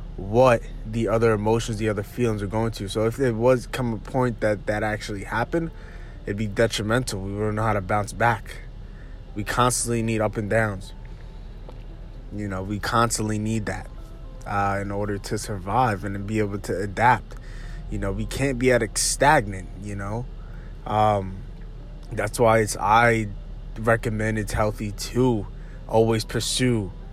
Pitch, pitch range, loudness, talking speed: 110 Hz, 105-120 Hz, -24 LUFS, 165 wpm